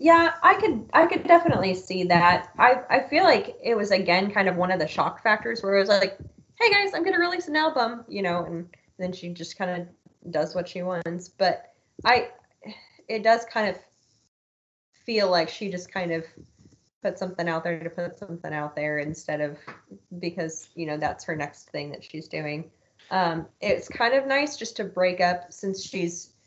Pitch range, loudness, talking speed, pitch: 165-220 Hz, -24 LUFS, 205 wpm, 180 Hz